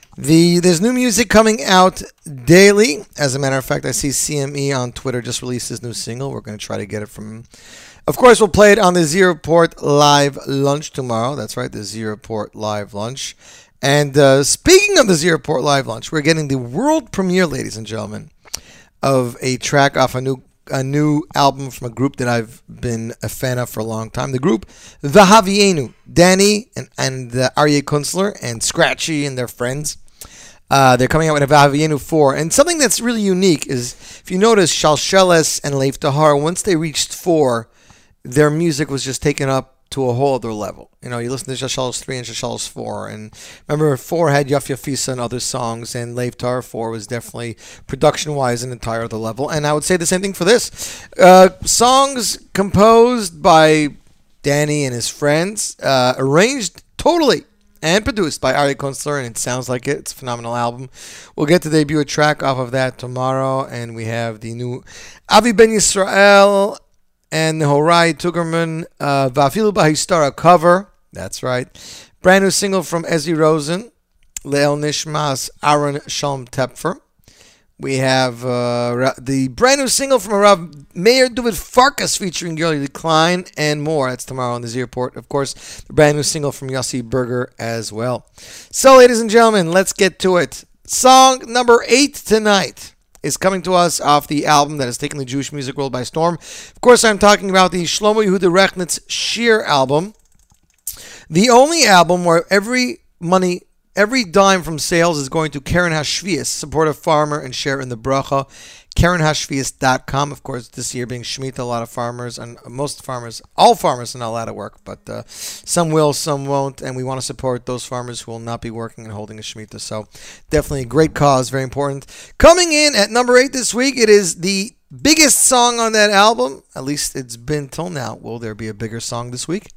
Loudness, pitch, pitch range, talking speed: -15 LUFS, 145 Hz, 125-180 Hz, 190 wpm